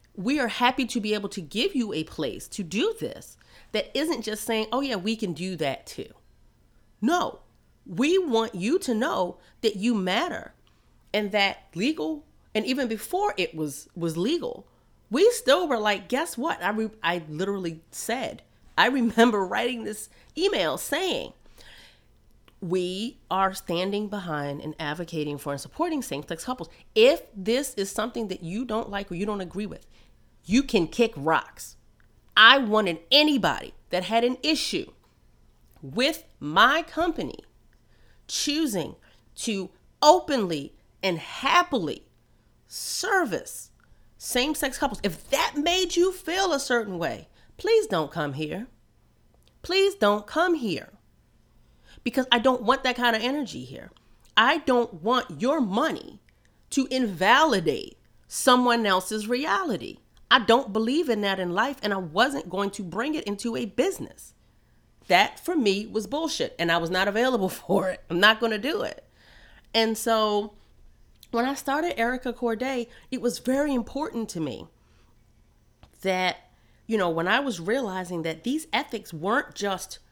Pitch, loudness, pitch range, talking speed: 225 Hz, -25 LUFS, 185-265 Hz, 155 wpm